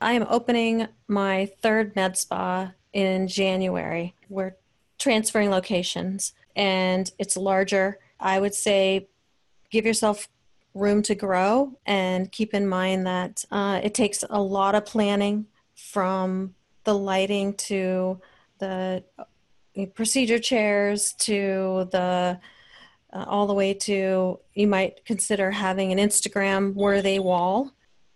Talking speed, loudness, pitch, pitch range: 120 wpm, -24 LUFS, 195 Hz, 190-210 Hz